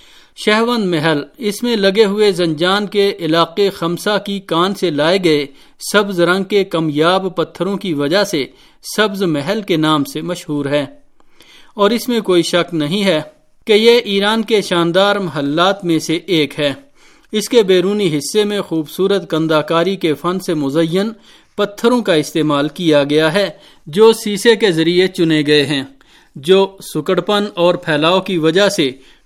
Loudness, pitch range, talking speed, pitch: -15 LUFS, 160-205 Hz, 160 wpm, 185 Hz